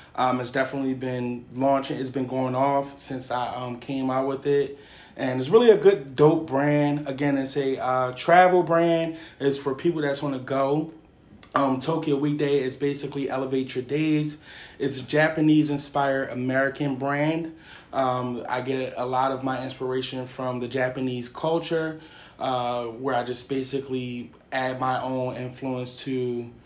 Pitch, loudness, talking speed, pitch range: 135 Hz, -25 LUFS, 160 wpm, 130-145 Hz